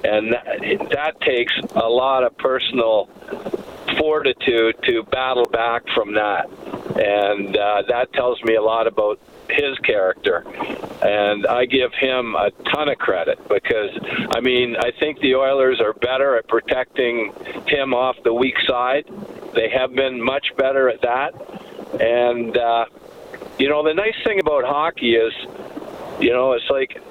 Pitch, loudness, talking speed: 130 Hz, -19 LUFS, 155 wpm